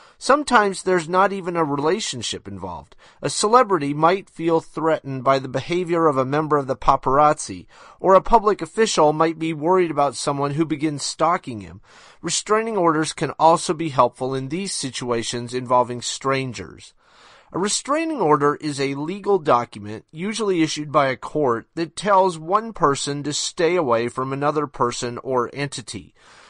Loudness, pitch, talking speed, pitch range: -20 LUFS, 150 Hz, 155 wpm, 130-180 Hz